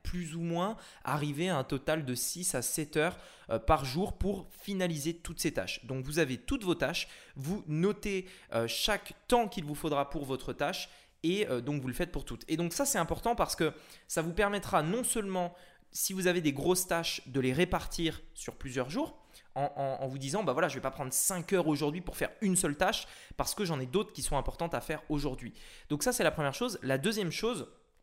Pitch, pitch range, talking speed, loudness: 165 Hz, 140-185 Hz, 230 wpm, -33 LUFS